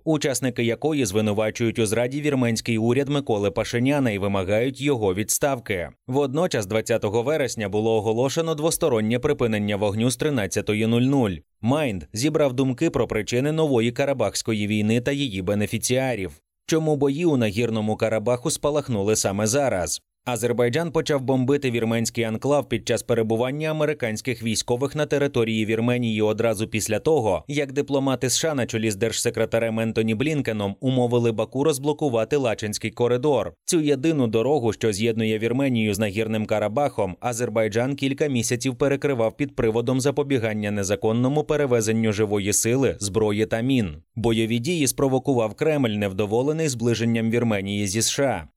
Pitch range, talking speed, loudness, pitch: 110-140 Hz, 130 wpm, -23 LUFS, 120 Hz